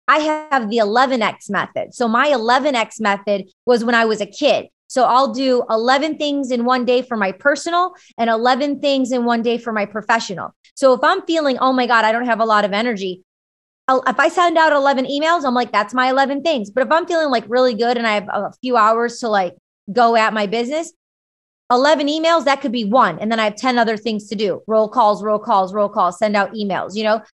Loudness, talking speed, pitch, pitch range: -17 LUFS, 230 wpm, 245 Hz, 220-275 Hz